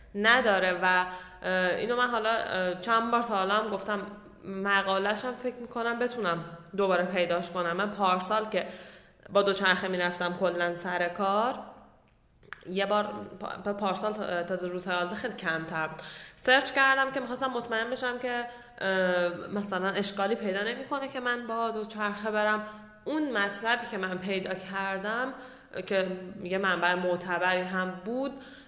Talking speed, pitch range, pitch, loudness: 135 wpm, 185-230 Hz, 200 Hz, -29 LUFS